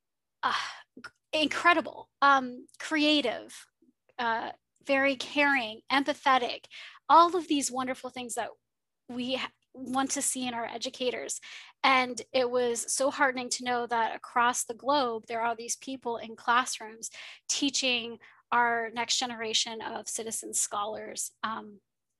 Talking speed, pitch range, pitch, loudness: 125 wpm, 235-275 Hz, 250 Hz, -28 LUFS